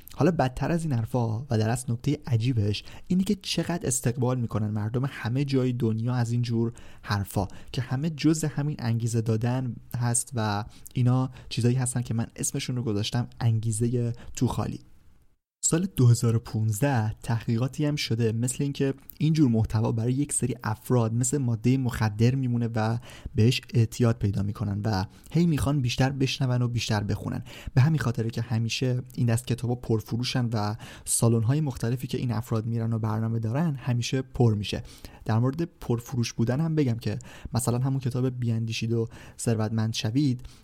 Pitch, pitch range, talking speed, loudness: 120 Hz, 115-130 Hz, 160 wpm, -27 LUFS